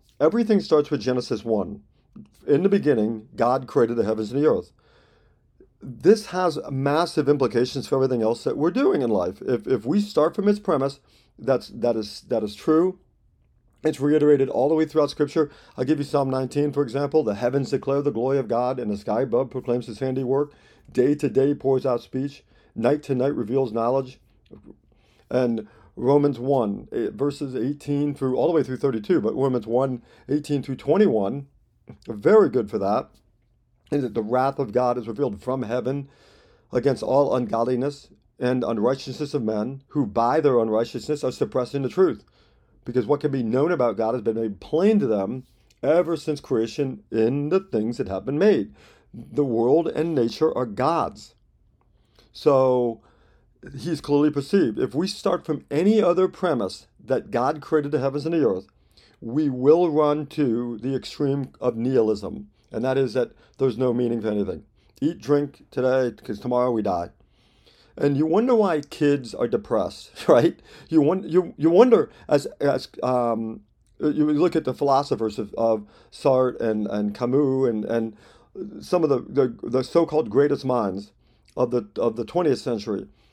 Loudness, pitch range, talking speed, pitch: -23 LUFS, 120-145 Hz, 175 wpm, 135 Hz